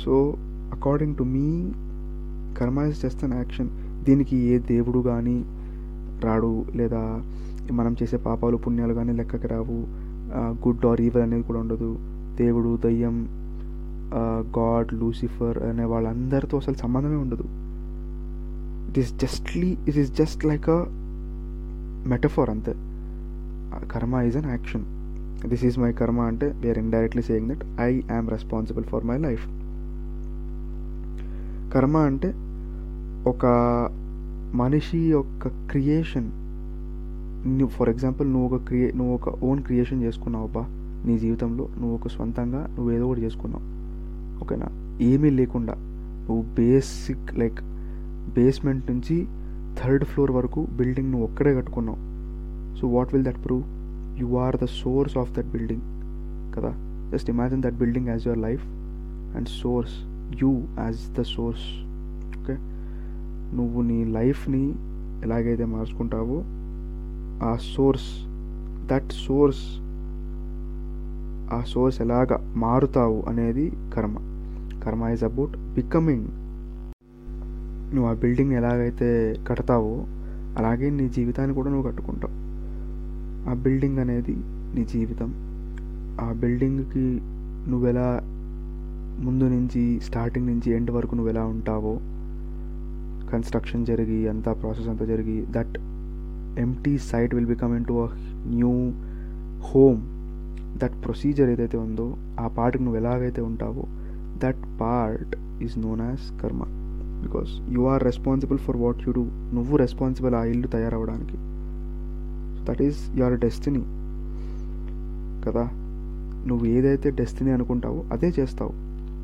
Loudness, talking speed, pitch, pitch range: -26 LUFS, 115 wpm, 115 Hz, 85-125 Hz